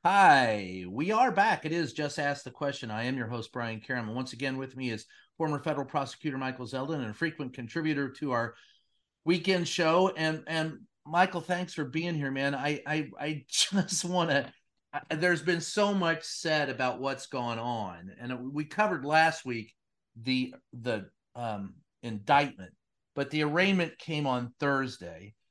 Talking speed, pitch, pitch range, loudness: 170 wpm, 140 Hz, 125-160 Hz, -30 LUFS